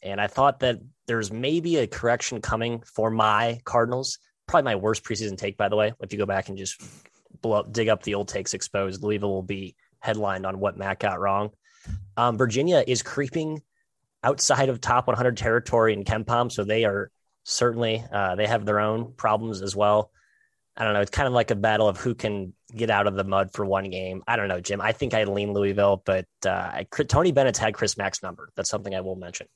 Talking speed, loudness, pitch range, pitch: 220 wpm, -25 LUFS, 100-120 Hz, 110 Hz